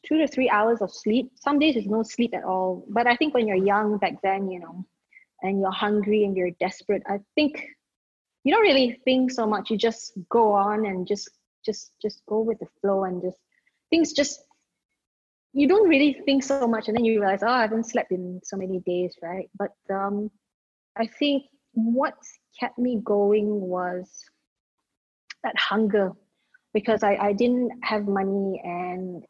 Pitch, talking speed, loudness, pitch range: 215 Hz, 185 wpm, -24 LUFS, 195-245 Hz